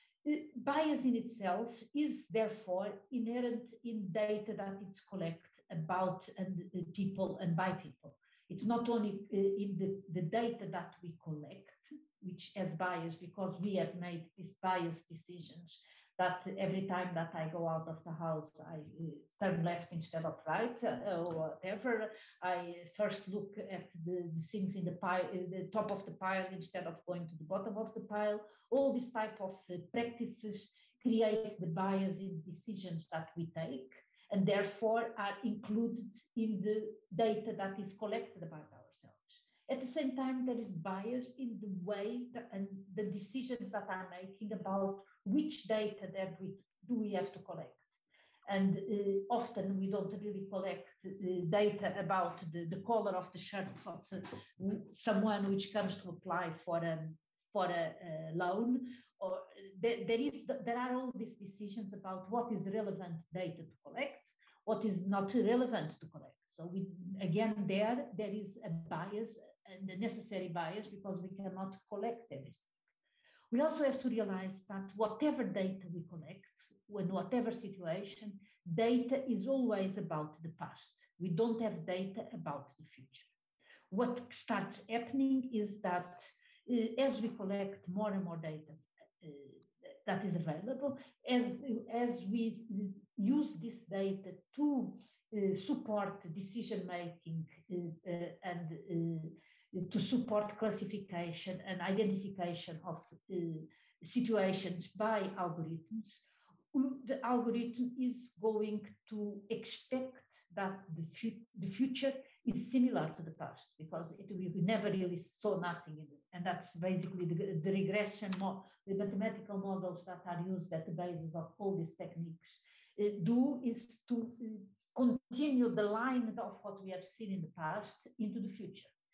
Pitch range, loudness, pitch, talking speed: 180-225 Hz, -39 LUFS, 195 Hz, 155 wpm